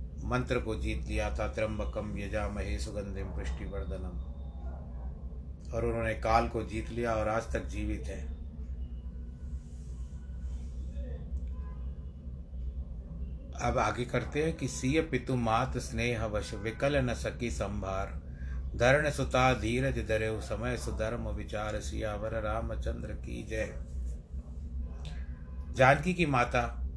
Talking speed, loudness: 105 wpm, -34 LUFS